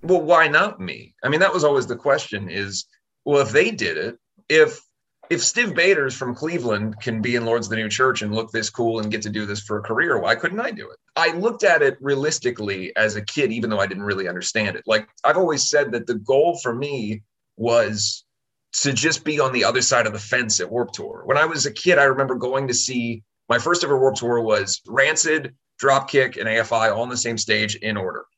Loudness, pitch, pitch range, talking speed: -20 LUFS, 120 Hz, 110-135 Hz, 240 wpm